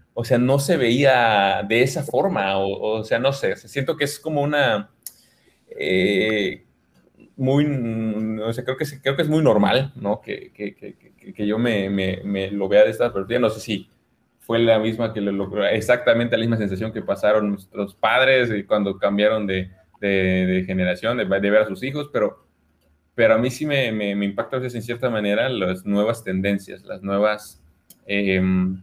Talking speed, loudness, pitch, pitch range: 195 wpm, -21 LUFS, 110 Hz, 95-125 Hz